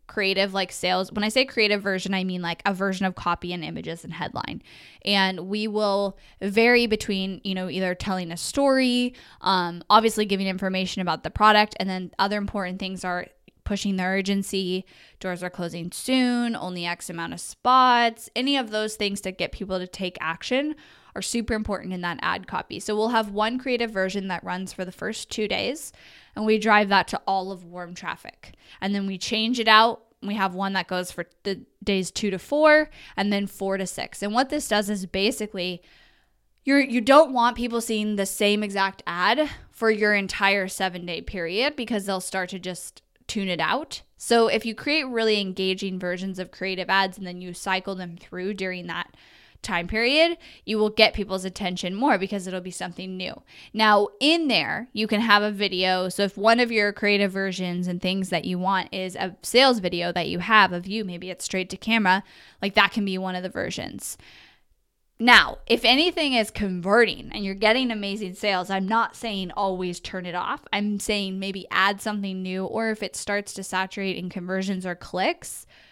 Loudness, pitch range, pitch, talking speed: -24 LUFS, 185-220 Hz, 195 Hz, 200 wpm